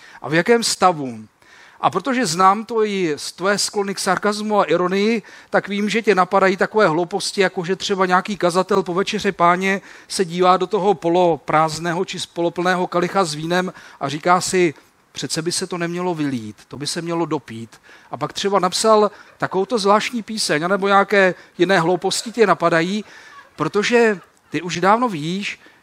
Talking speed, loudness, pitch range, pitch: 170 wpm, -19 LUFS, 175-205 Hz, 185 Hz